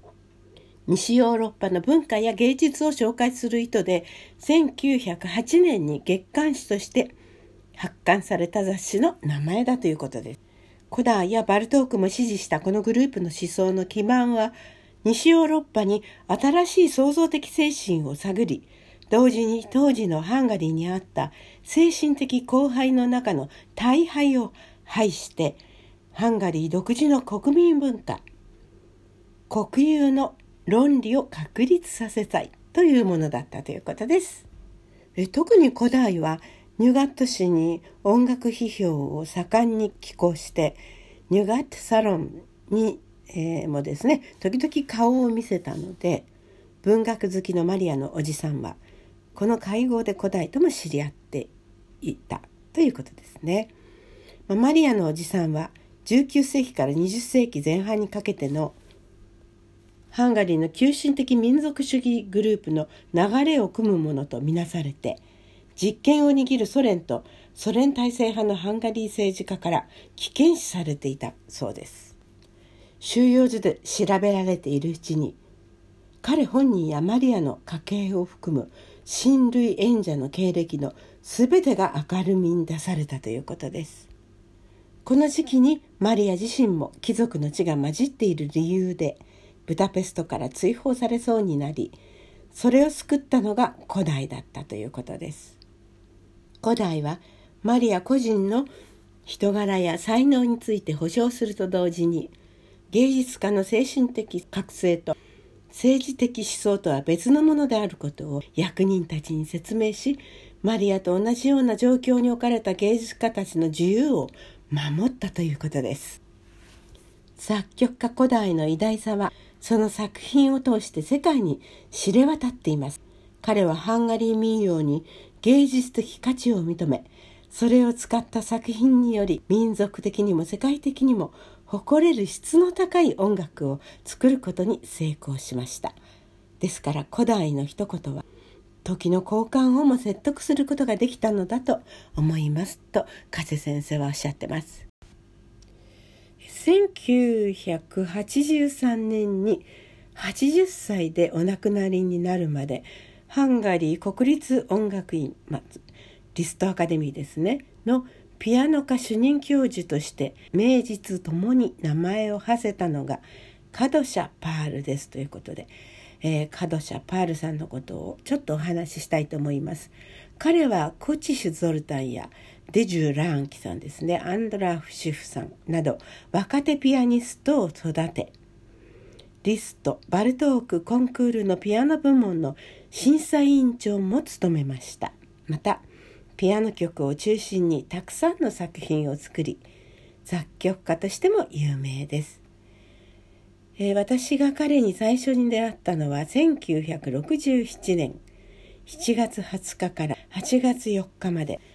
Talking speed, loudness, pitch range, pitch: 275 characters per minute, -24 LUFS, 155-245 Hz, 195 Hz